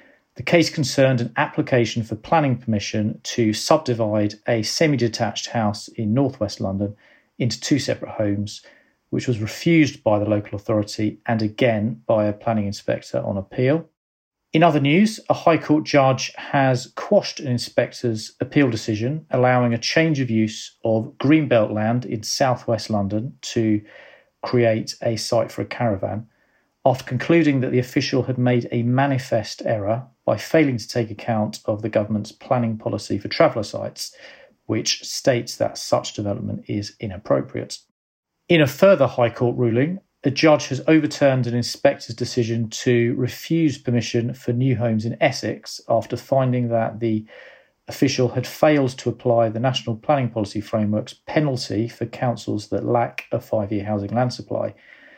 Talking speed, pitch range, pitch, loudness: 155 wpm, 110-135 Hz, 120 Hz, -21 LUFS